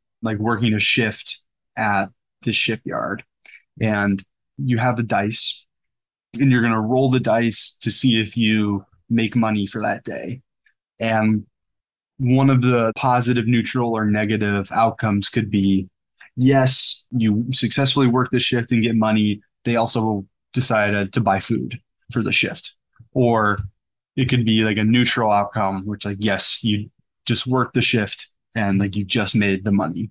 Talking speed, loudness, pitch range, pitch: 160 wpm, -19 LUFS, 105-120 Hz, 110 Hz